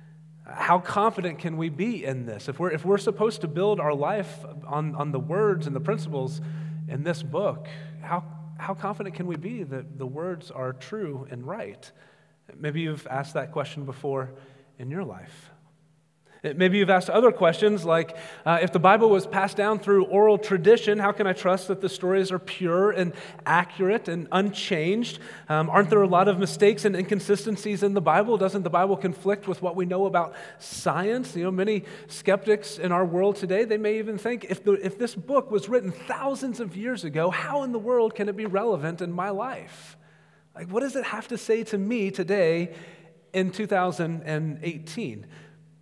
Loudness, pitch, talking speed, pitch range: -25 LUFS, 185 Hz, 190 wpm, 160-205 Hz